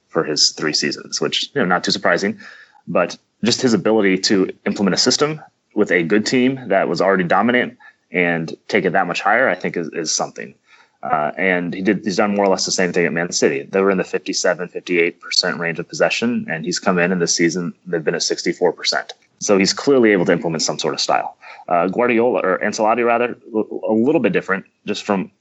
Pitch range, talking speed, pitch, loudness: 95-120 Hz, 220 wpm, 105 Hz, -18 LUFS